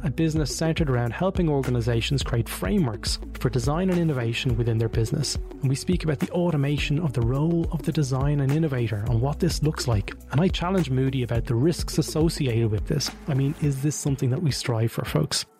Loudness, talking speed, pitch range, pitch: -25 LUFS, 210 wpm, 120-160 Hz, 140 Hz